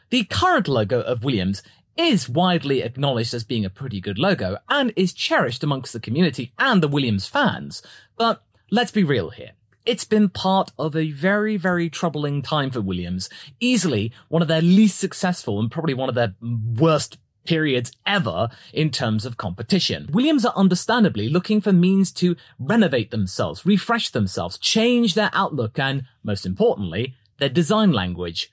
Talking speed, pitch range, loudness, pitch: 165 wpm, 115-190 Hz, -21 LUFS, 155 Hz